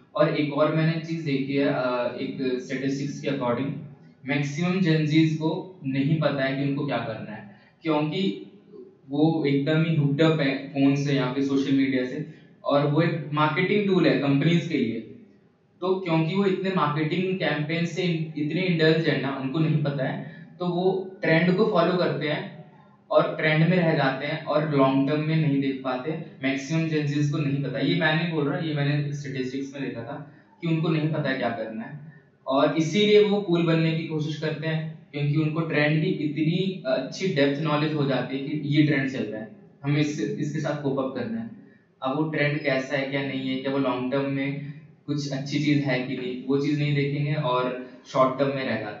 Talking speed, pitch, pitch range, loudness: 200 wpm, 150 Hz, 140-160 Hz, -25 LUFS